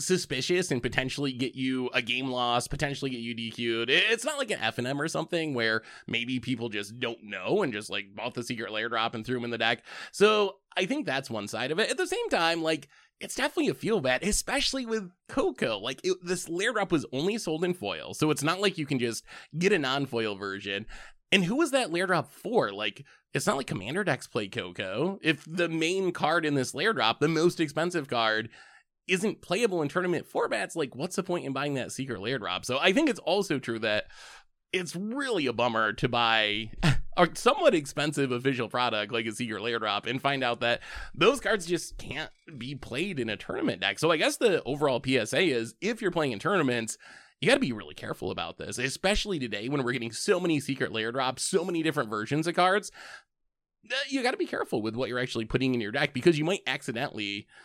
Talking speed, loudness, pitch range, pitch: 225 wpm, -28 LUFS, 120-180 Hz, 140 Hz